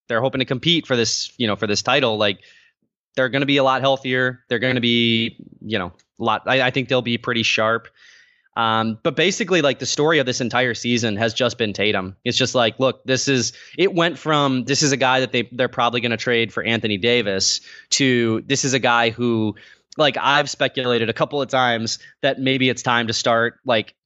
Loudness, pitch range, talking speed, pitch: -19 LUFS, 115-135 Hz, 220 wpm, 125 Hz